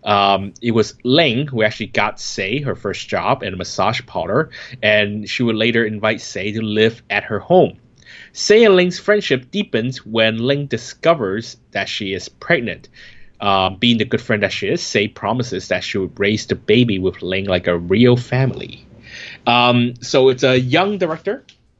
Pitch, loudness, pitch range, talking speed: 120 Hz, -17 LUFS, 105-130 Hz, 180 wpm